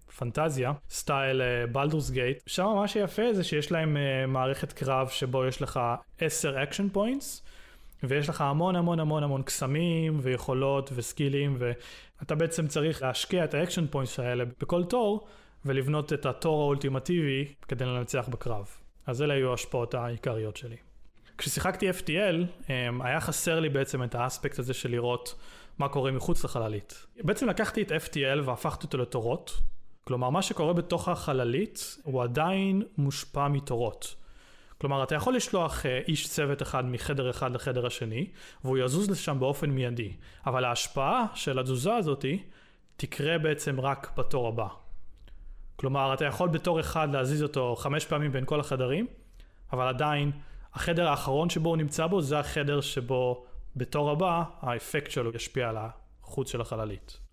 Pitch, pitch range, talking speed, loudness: 140 Hz, 125-160 Hz, 145 wpm, -30 LUFS